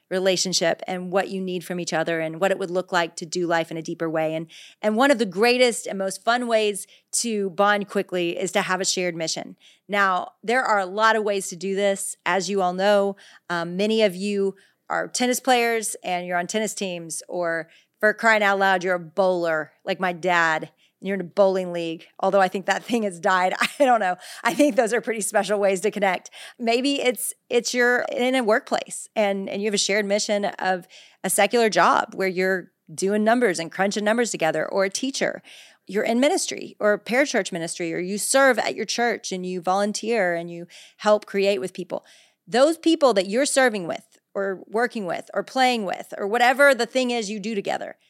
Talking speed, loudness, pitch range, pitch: 215 wpm, -22 LUFS, 180-225 Hz, 200 Hz